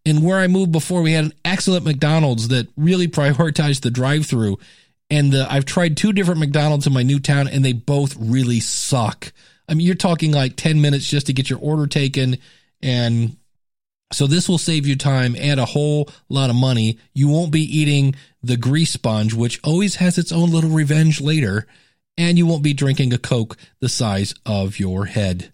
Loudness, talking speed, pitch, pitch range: -18 LUFS, 195 wpm, 145 Hz, 125-160 Hz